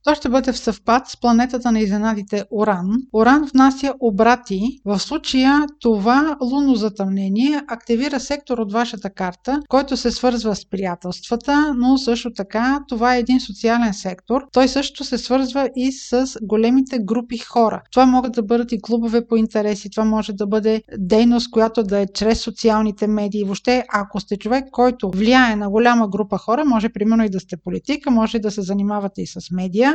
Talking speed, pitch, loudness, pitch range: 175 wpm, 230 Hz, -18 LUFS, 210-255 Hz